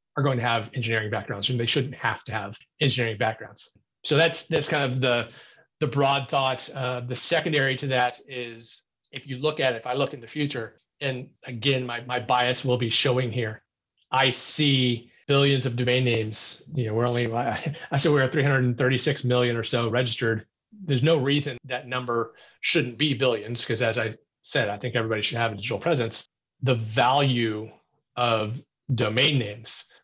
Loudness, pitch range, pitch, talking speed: -25 LUFS, 115-140 Hz, 125 Hz, 190 wpm